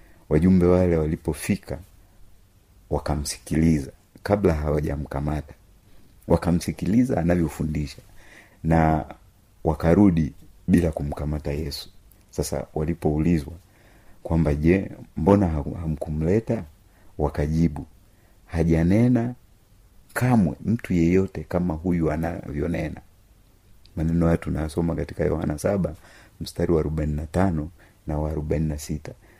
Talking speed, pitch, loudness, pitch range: 90 wpm, 85 Hz, -24 LUFS, 80-95 Hz